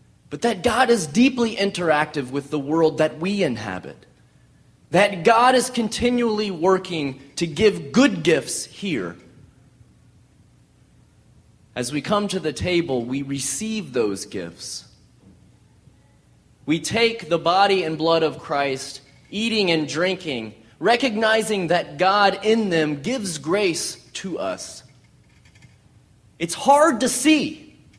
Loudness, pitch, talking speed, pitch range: -21 LUFS, 170 Hz, 120 wpm, 140-220 Hz